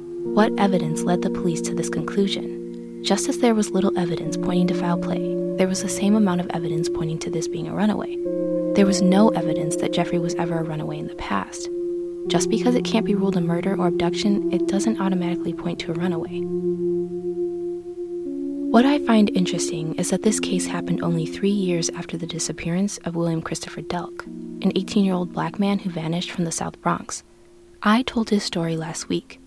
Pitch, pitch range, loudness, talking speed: 175 Hz, 170-195 Hz, -23 LUFS, 200 wpm